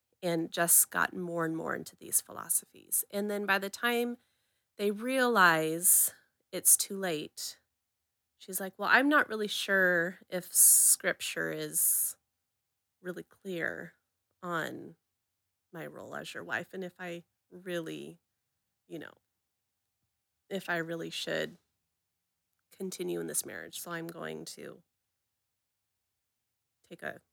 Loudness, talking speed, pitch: -28 LUFS, 125 wpm, 165 Hz